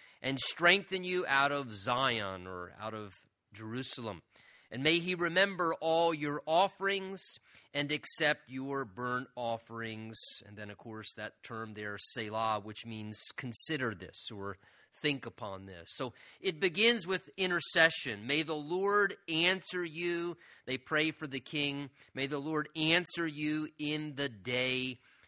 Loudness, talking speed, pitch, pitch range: -33 LUFS, 145 wpm, 140 Hz, 110-165 Hz